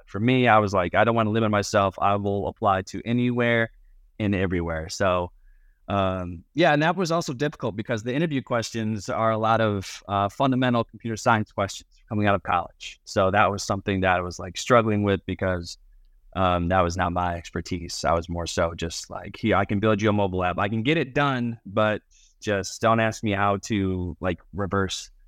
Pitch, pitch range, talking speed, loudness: 100 Hz, 90-115 Hz, 210 wpm, -24 LUFS